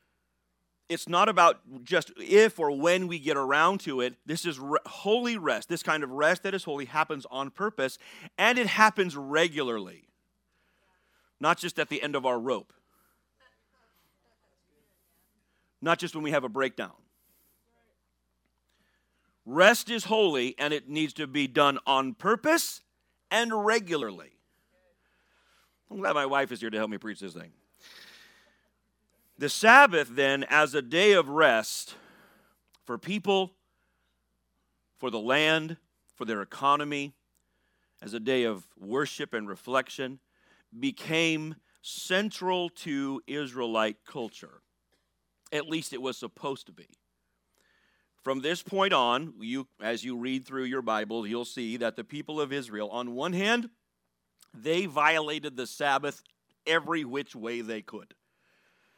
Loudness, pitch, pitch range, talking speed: -27 LUFS, 145 Hz, 120-175 Hz, 140 wpm